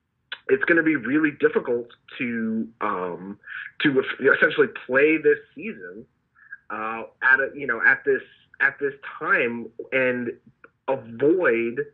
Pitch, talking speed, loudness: 400 Hz, 135 wpm, -22 LUFS